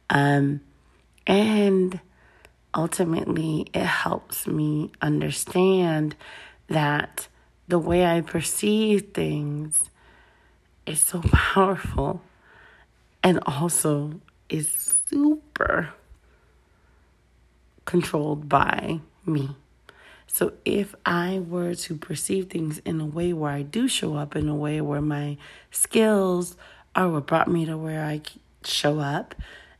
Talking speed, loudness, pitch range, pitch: 105 wpm, -24 LUFS, 150-180 Hz, 160 Hz